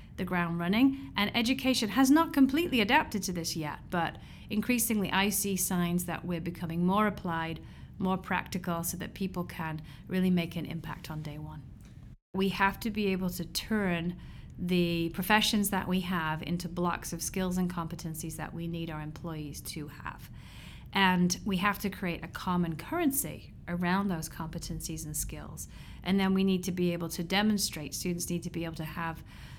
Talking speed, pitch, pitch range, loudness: 180 wpm, 180 Hz, 165-195 Hz, -31 LUFS